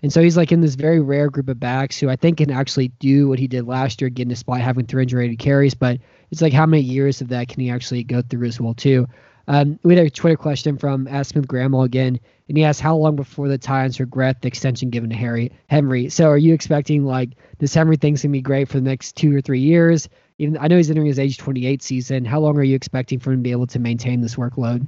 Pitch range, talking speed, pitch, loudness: 125-150 Hz, 270 wpm, 135 Hz, -18 LUFS